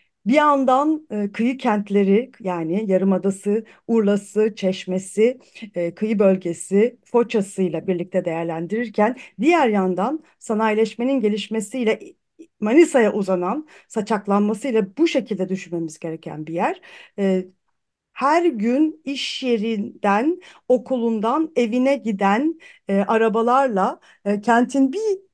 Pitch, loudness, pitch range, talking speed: 220 Hz, -21 LUFS, 195-260 Hz, 100 wpm